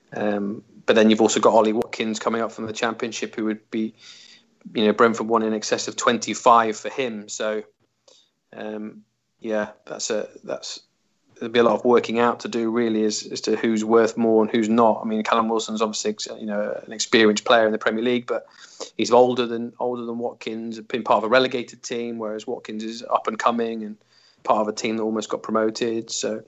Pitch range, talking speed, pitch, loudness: 110-115 Hz, 215 wpm, 110 Hz, -22 LUFS